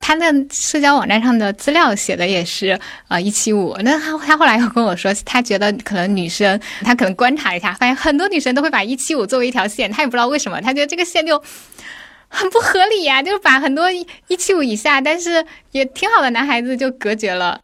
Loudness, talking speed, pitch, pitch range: -15 LUFS, 345 characters per minute, 265 Hz, 210-310 Hz